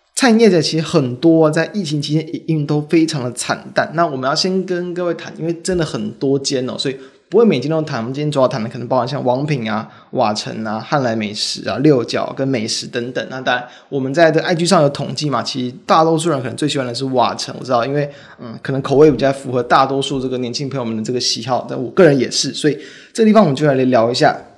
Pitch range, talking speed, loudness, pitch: 130-160 Hz, 380 characters per minute, -16 LUFS, 140 Hz